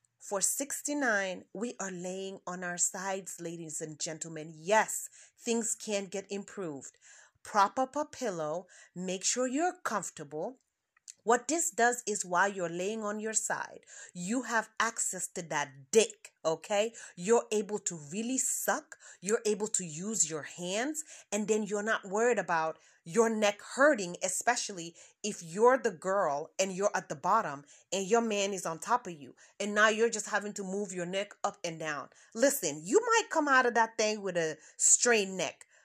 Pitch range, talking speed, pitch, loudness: 180-230 Hz, 170 wpm, 205 Hz, -31 LUFS